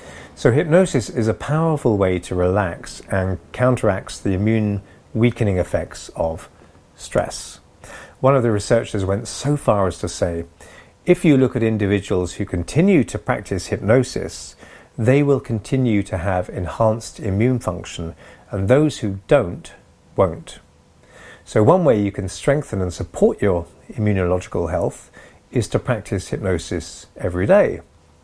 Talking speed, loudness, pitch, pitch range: 140 wpm, -20 LUFS, 105 Hz, 90-125 Hz